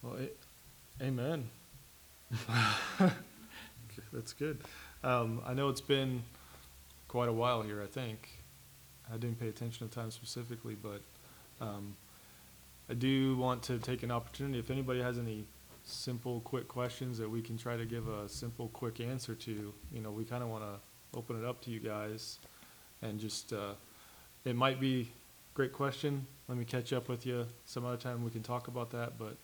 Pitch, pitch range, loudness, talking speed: 120 Hz, 110-125 Hz, -38 LUFS, 180 wpm